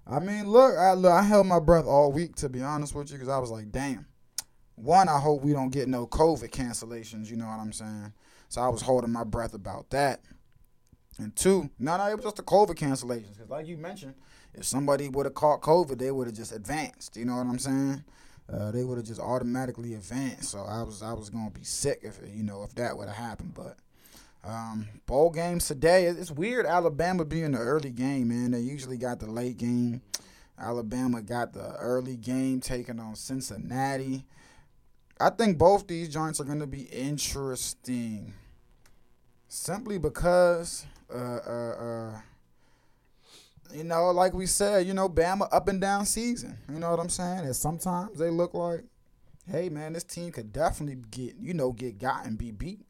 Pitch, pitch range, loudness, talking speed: 135 Hz, 120-170 Hz, -28 LUFS, 200 wpm